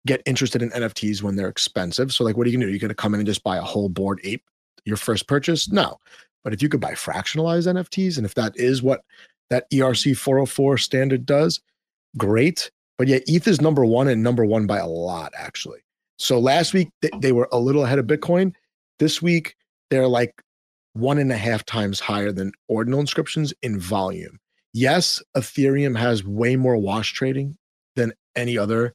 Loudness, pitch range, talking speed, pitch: -21 LUFS, 110-140 Hz, 205 wpm, 125 Hz